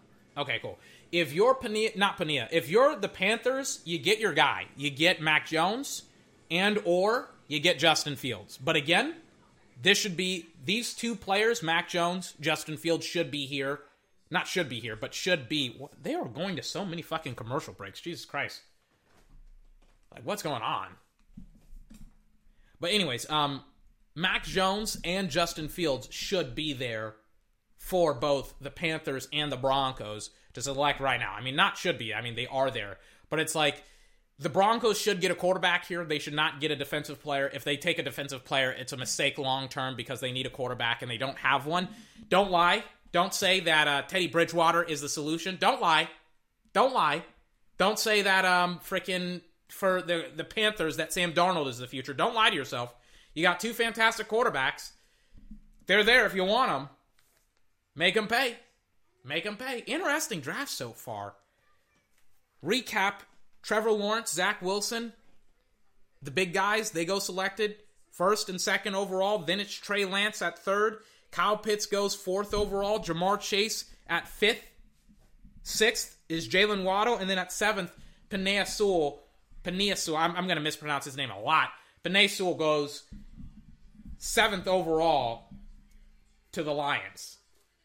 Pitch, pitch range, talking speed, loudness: 170 Hz, 140-200 Hz, 165 wpm, -28 LUFS